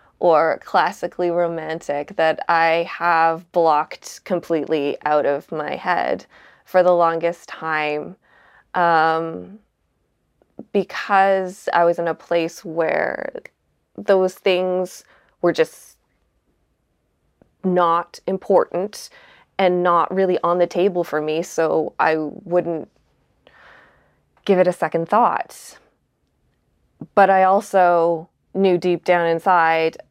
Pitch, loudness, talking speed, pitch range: 175 Hz, -19 LUFS, 105 wpm, 165-185 Hz